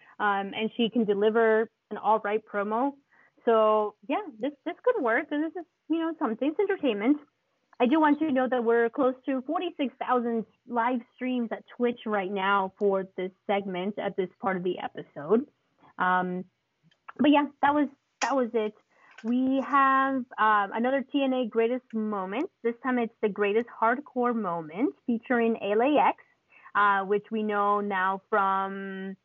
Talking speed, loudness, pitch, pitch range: 165 wpm, -27 LUFS, 230 Hz, 205-270 Hz